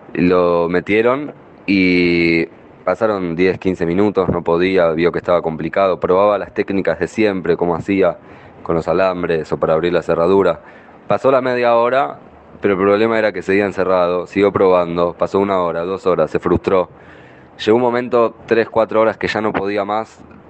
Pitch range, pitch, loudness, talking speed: 85-105 Hz, 95 Hz, -16 LUFS, 175 wpm